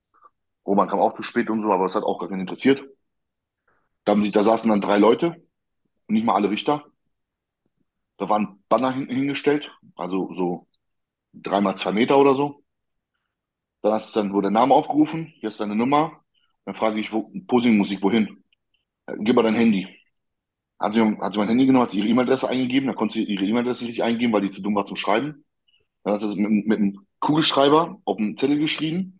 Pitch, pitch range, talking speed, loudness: 110 Hz, 105-135 Hz, 205 wpm, -22 LUFS